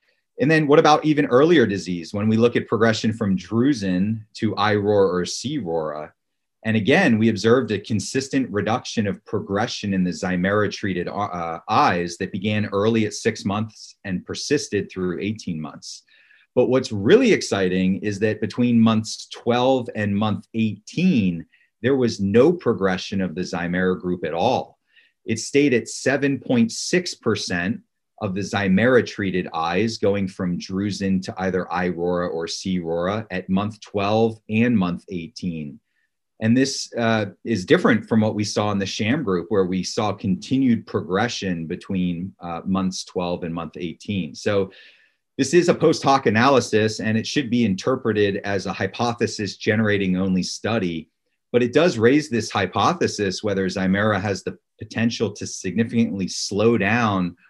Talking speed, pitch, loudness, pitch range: 155 wpm, 105 Hz, -21 LUFS, 95-115 Hz